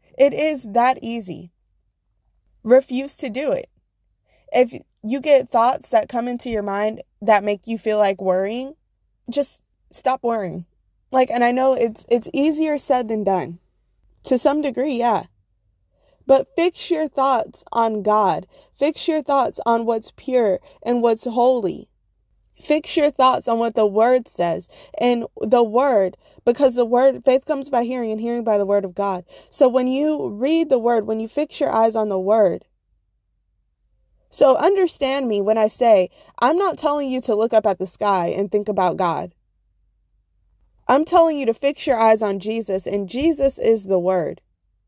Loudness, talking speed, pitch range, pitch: -19 LUFS, 170 wpm, 200-270 Hz, 235 Hz